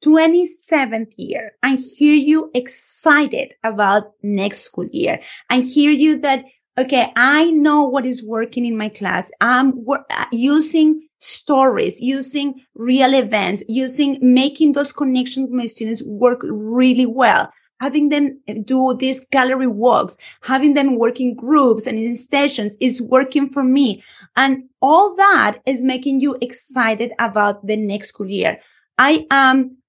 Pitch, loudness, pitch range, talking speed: 260 Hz, -16 LUFS, 235-280 Hz, 145 wpm